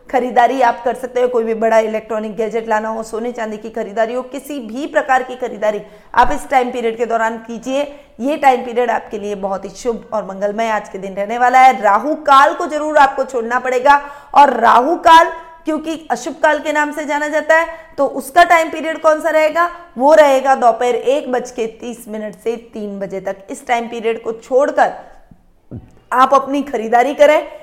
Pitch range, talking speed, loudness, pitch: 225-290 Hz, 200 wpm, -15 LUFS, 250 Hz